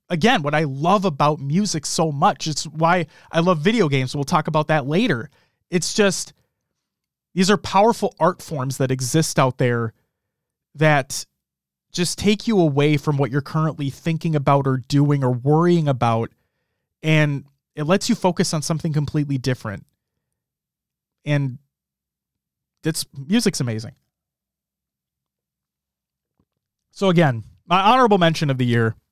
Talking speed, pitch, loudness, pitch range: 140 wpm, 150 Hz, -20 LUFS, 130-170 Hz